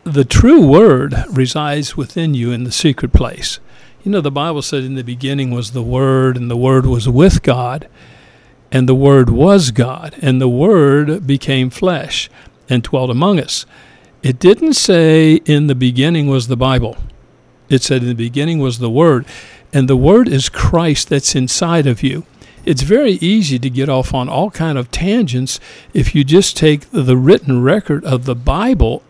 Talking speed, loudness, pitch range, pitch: 180 wpm, -13 LUFS, 130-160 Hz, 135 Hz